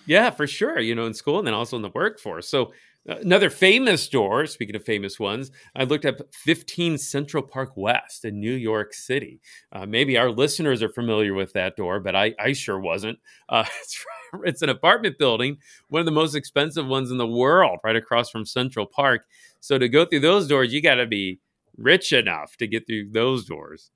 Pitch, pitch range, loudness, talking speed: 125 Hz, 110-145 Hz, -22 LUFS, 210 wpm